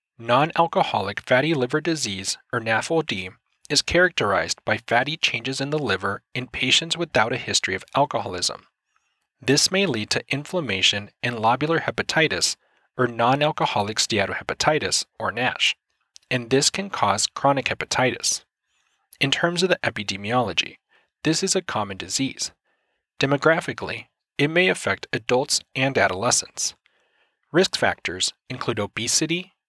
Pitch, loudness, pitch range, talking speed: 130 Hz, -22 LUFS, 115-160 Hz, 125 wpm